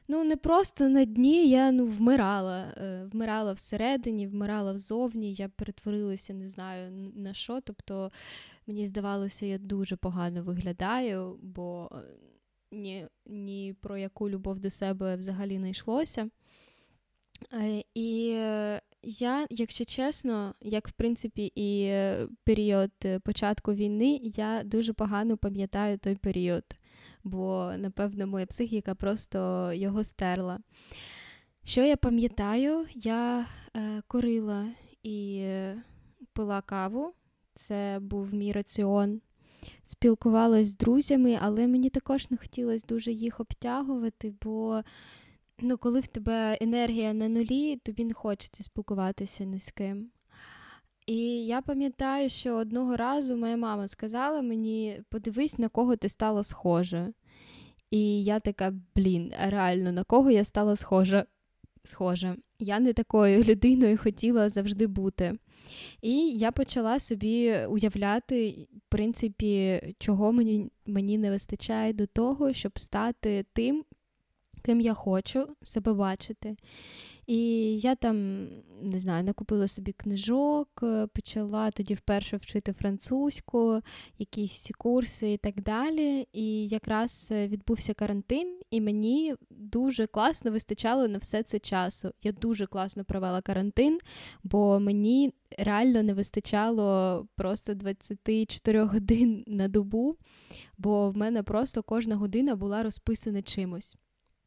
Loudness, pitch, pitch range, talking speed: -29 LUFS, 215 Hz, 200-235 Hz, 120 wpm